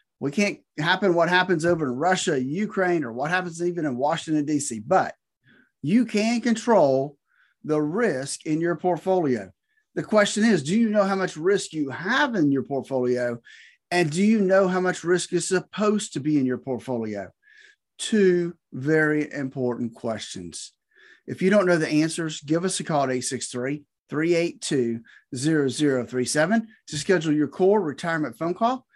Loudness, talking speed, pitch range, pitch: -24 LUFS, 160 wpm, 140-190 Hz, 165 Hz